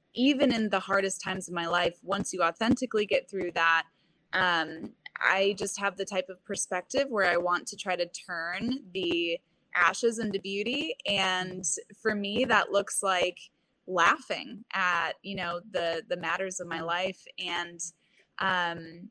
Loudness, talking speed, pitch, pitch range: -29 LUFS, 160 wpm, 185 Hz, 175-205 Hz